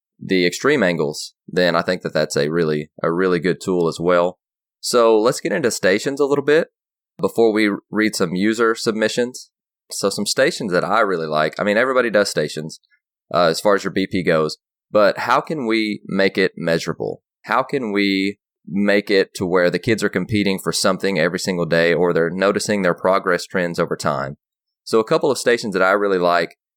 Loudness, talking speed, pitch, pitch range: -19 LUFS, 200 wpm, 95 Hz, 85-105 Hz